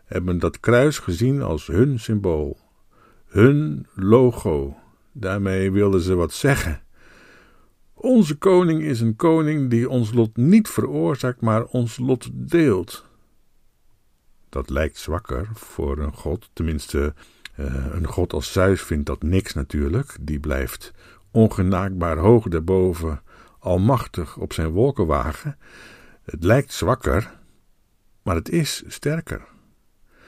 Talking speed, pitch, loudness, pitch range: 115 wpm, 95 Hz, -21 LUFS, 80-125 Hz